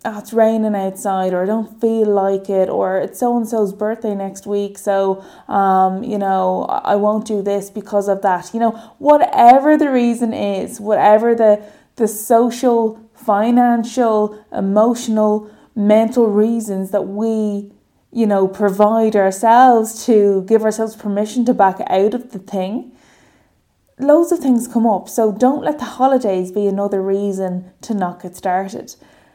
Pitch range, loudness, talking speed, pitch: 200-230 Hz, -16 LUFS, 155 wpm, 215 Hz